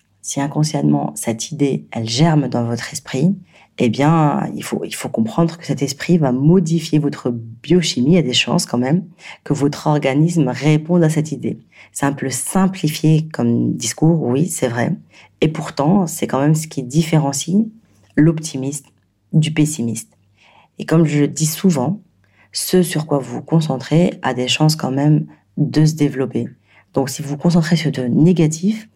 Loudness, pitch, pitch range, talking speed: -17 LUFS, 150 Hz, 125-165 Hz, 170 wpm